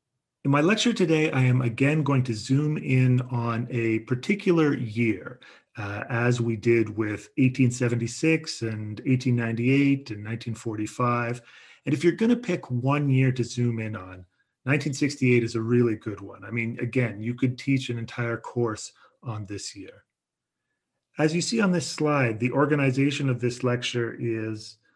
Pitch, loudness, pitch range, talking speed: 125 Hz, -25 LUFS, 115-140 Hz, 160 wpm